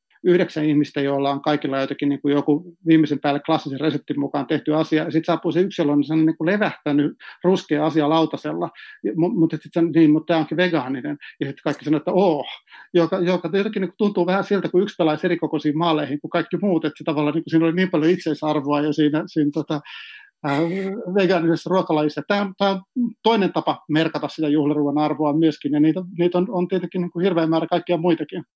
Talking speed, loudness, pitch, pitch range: 200 wpm, -21 LUFS, 160 Hz, 150-180 Hz